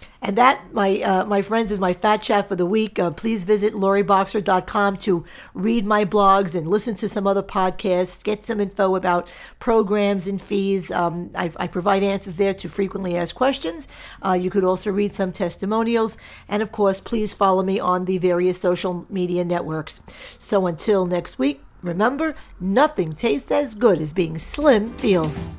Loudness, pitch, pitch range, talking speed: -21 LUFS, 195 Hz, 180-210 Hz, 180 wpm